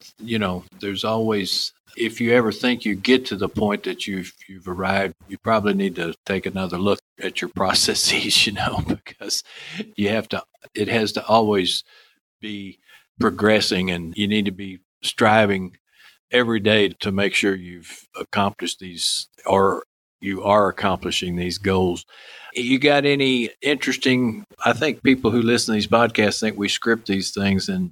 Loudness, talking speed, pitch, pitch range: -21 LUFS, 165 wpm, 105 Hz, 95-115 Hz